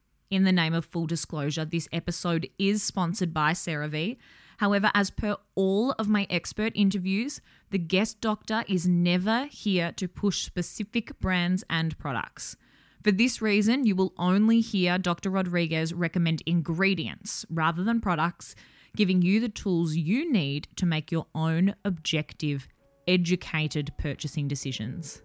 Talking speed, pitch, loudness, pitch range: 145 wpm, 180 Hz, -27 LUFS, 165-205 Hz